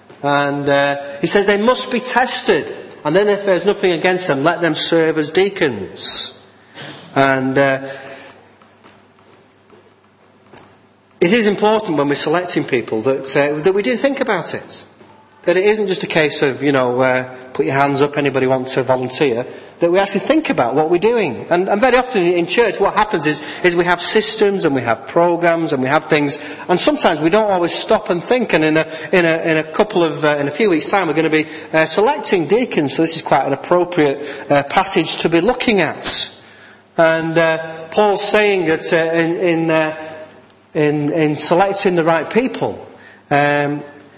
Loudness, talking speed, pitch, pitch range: -15 LUFS, 195 wpm, 165 Hz, 145-195 Hz